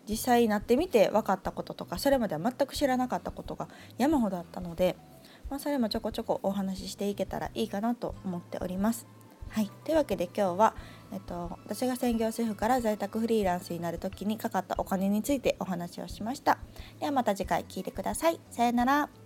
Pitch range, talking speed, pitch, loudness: 190-245 Hz, 445 characters per minute, 215 Hz, -30 LUFS